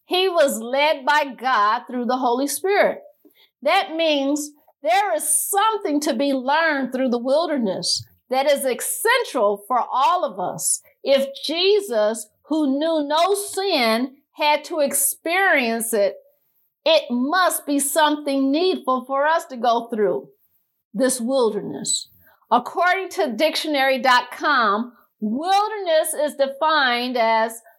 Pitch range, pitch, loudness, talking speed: 245-320 Hz, 285 Hz, -20 LUFS, 120 wpm